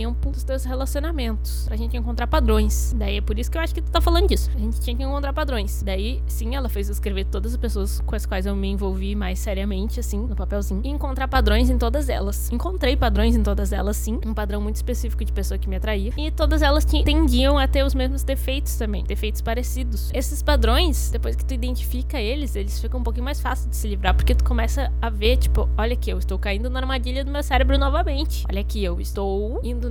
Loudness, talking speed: -23 LUFS, 235 wpm